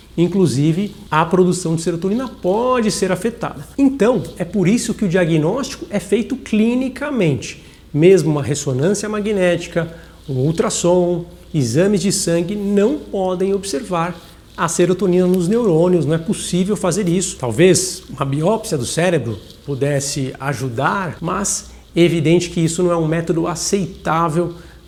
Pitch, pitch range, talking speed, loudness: 180 Hz, 165-200 Hz, 135 wpm, -17 LUFS